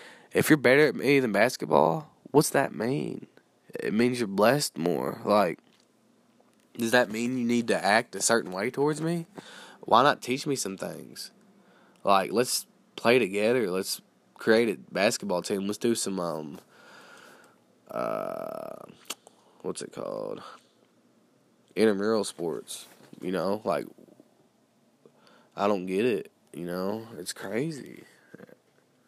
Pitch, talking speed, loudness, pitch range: 110 Hz, 130 wpm, -27 LUFS, 95-120 Hz